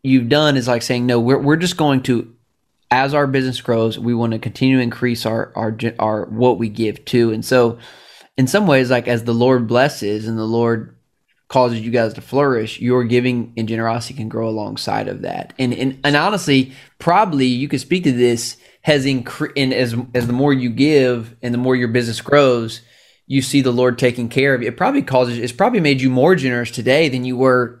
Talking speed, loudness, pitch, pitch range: 220 wpm, -17 LUFS, 125 Hz, 115-135 Hz